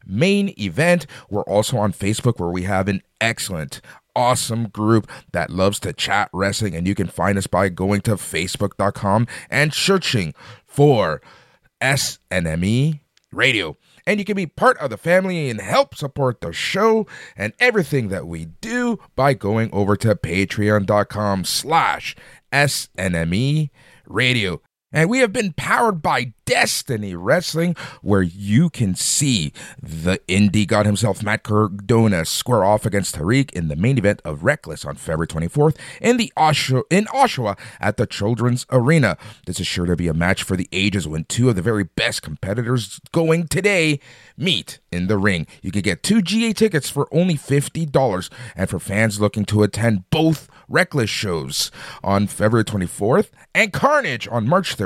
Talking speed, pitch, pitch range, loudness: 160 wpm, 115 Hz, 100-150 Hz, -19 LUFS